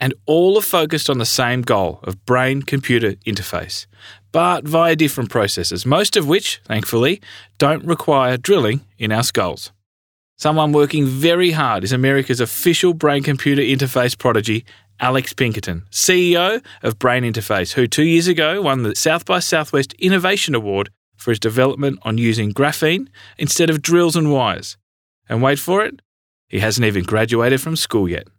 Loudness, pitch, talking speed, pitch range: -17 LUFS, 130 Hz, 160 wpm, 110-155 Hz